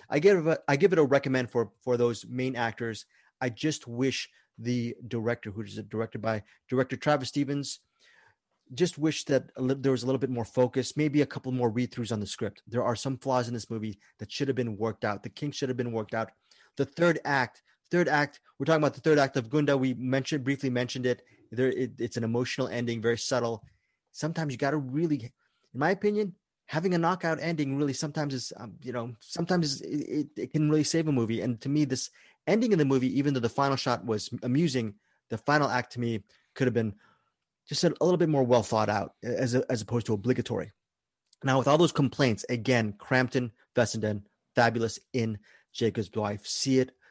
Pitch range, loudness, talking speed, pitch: 115-145 Hz, -29 LUFS, 215 wpm, 130 Hz